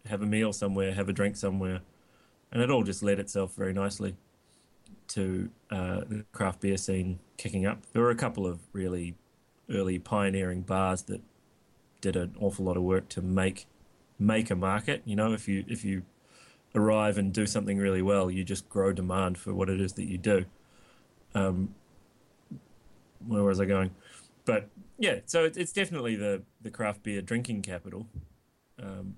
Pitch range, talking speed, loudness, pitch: 95-105 Hz, 175 wpm, -30 LUFS, 100 Hz